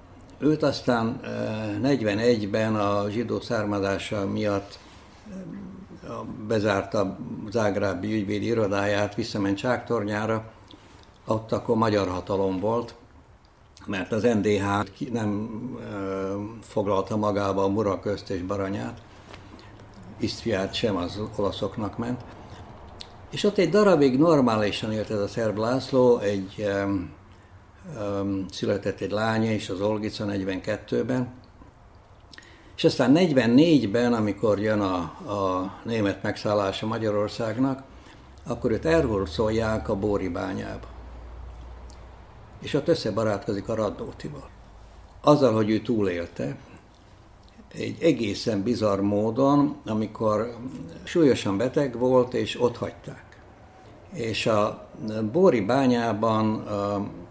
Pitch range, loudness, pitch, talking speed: 100-115 Hz, -25 LUFS, 105 Hz, 100 wpm